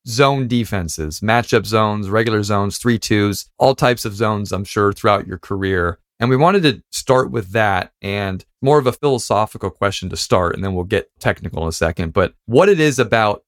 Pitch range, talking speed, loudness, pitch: 95-120 Hz, 200 wpm, -17 LUFS, 105 Hz